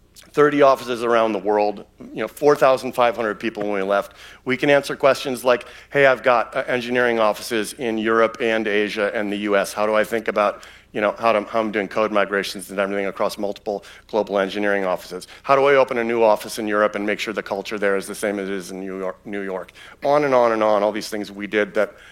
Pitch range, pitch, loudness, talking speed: 100-120 Hz, 110 Hz, -20 LUFS, 235 wpm